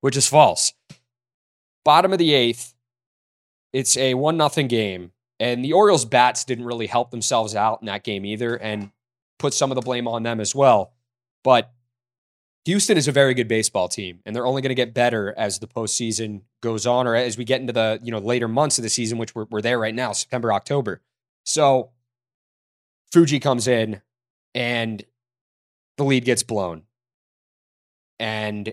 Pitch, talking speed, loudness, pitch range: 120 Hz, 180 wpm, -20 LUFS, 110-125 Hz